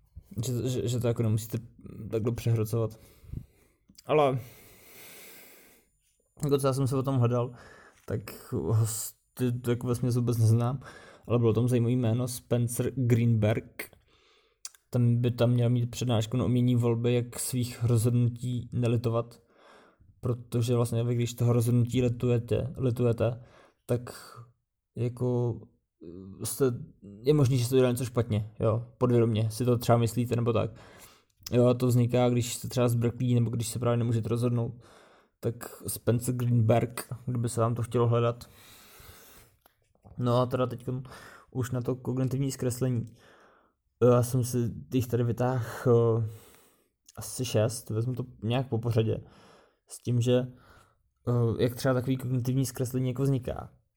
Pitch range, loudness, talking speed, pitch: 115-125 Hz, -28 LUFS, 140 wpm, 120 Hz